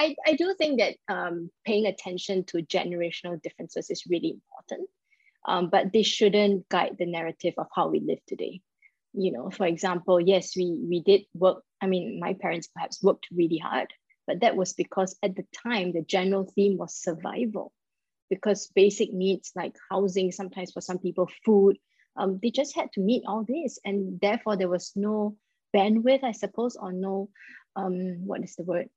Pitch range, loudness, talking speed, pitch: 180-215 Hz, -27 LUFS, 180 wpm, 195 Hz